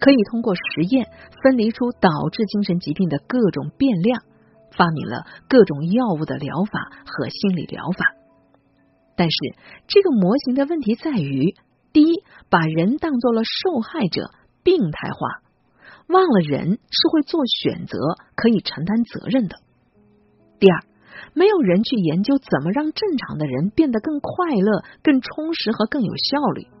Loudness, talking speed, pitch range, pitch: -20 LUFS, 230 characters per minute, 170-275 Hz, 215 Hz